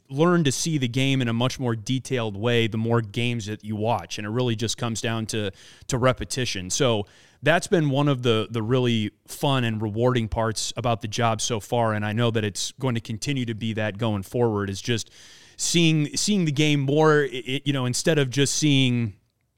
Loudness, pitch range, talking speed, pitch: -24 LUFS, 110-135 Hz, 220 wpm, 120 Hz